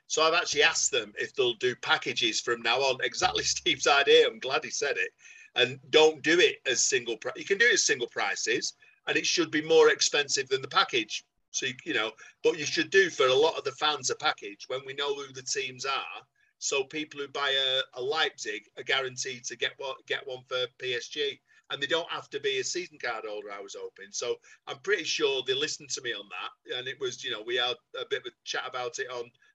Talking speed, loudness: 245 wpm, -27 LUFS